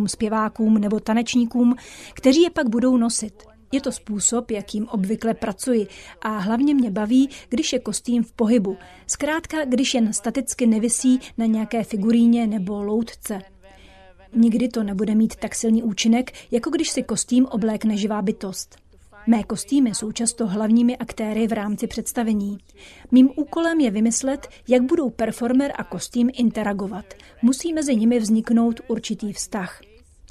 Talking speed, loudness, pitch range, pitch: 145 wpm, -21 LUFS, 215-250 Hz, 230 Hz